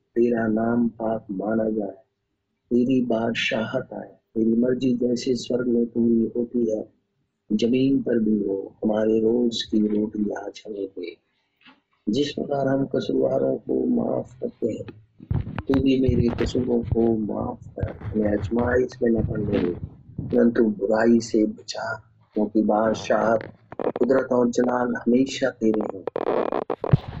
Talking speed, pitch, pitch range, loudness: 135 wpm, 115 Hz, 110-125 Hz, -23 LUFS